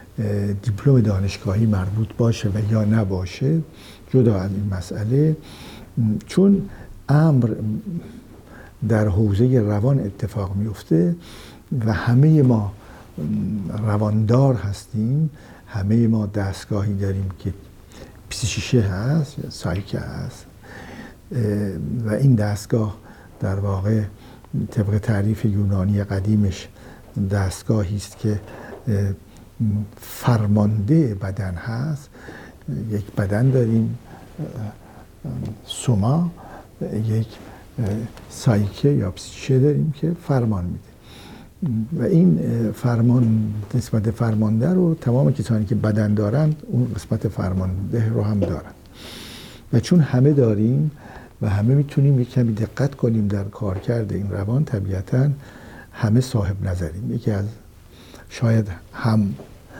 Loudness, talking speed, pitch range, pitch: -21 LUFS, 100 wpm, 100-125 Hz, 110 Hz